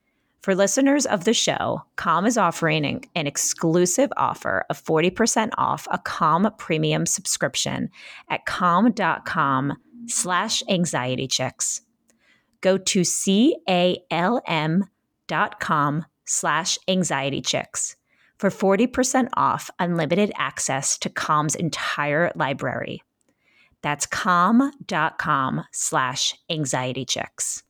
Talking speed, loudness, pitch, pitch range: 95 wpm, -22 LUFS, 180 Hz, 160-215 Hz